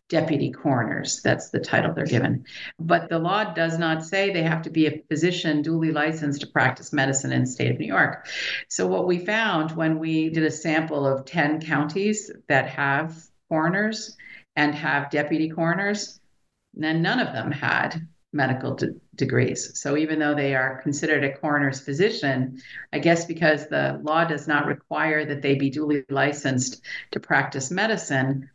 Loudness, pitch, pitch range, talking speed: -24 LUFS, 155 Hz, 140-165 Hz, 170 wpm